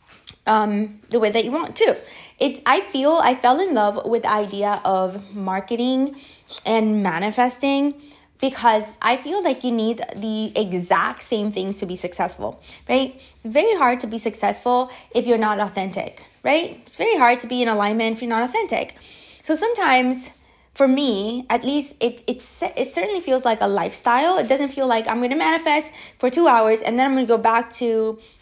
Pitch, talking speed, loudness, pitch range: 235 Hz, 190 wpm, -20 LUFS, 215-270 Hz